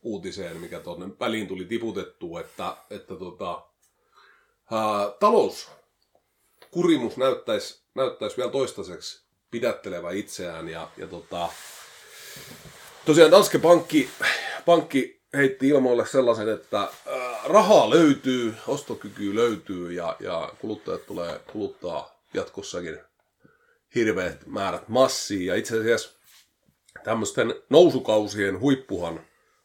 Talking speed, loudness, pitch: 95 wpm, -24 LUFS, 135 Hz